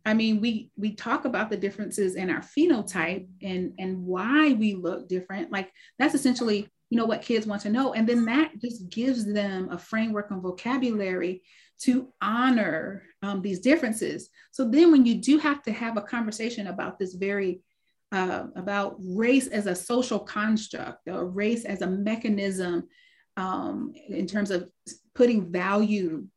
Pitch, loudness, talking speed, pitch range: 210 Hz, -26 LUFS, 165 wpm, 190-240 Hz